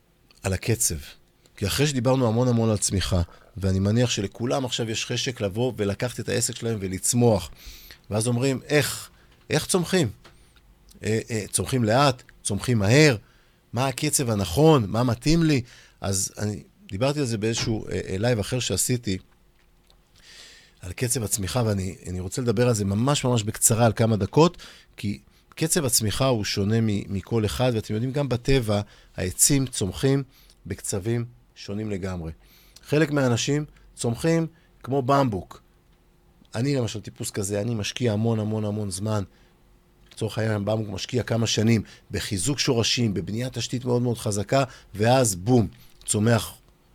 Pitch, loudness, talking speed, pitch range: 115 Hz, -24 LUFS, 140 wpm, 100-130 Hz